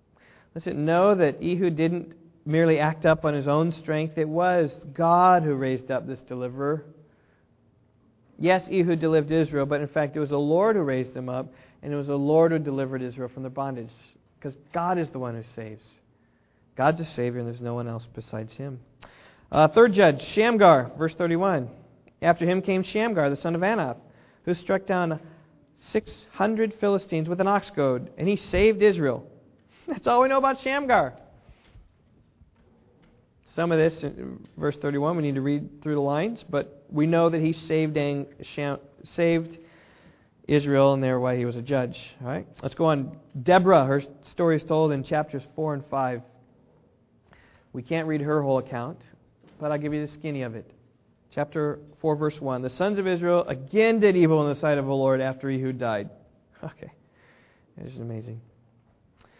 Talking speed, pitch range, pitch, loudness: 180 wpm, 130-165 Hz, 150 Hz, -24 LUFS